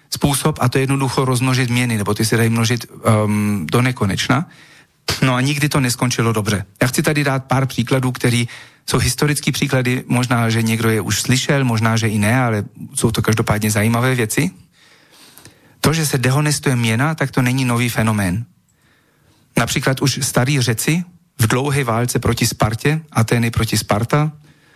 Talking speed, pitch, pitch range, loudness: 165 wpm, 125 Hz, 115-140 Hz, -17 LUFS